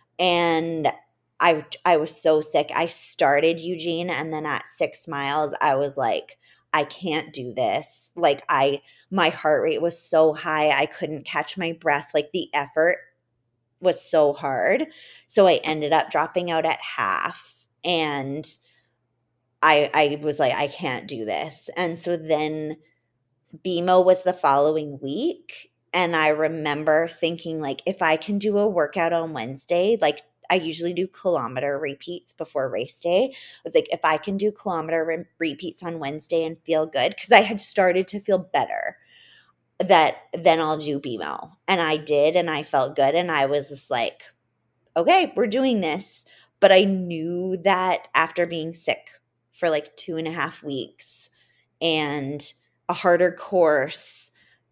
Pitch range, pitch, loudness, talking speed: 150-175 Hz, 160 Hz, -23 LUFS, 160 wpm